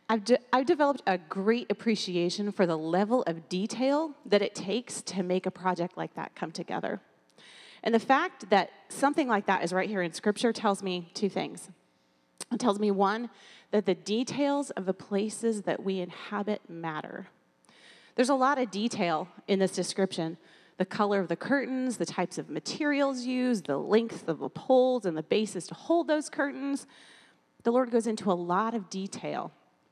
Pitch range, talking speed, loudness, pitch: 185-245 Hz, 180 wpm, -29 LUFS, 205 Hz